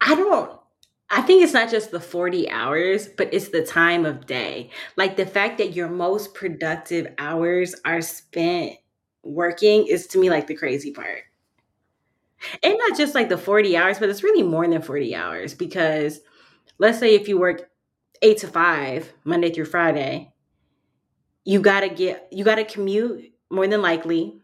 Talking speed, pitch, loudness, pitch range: 175 wpm, 180 Hz, -21 LUFS, 165-210 Hz